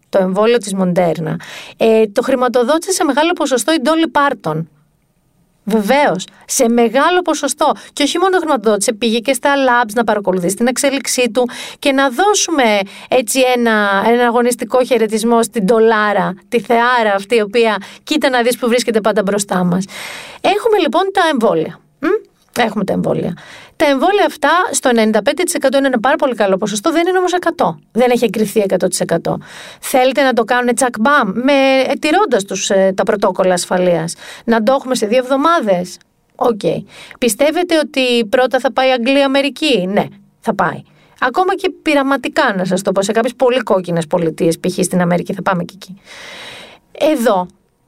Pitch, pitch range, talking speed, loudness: 245 Hz, 200-280 Hz, 160 wpm, -14 LUFS